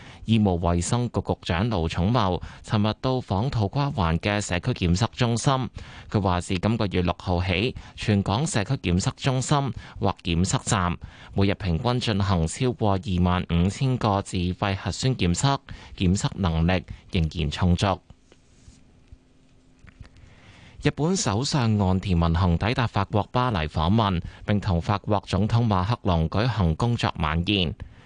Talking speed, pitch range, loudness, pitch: 220 characters per minute, 90-115 Hz, -24 LUFS, 100 Hz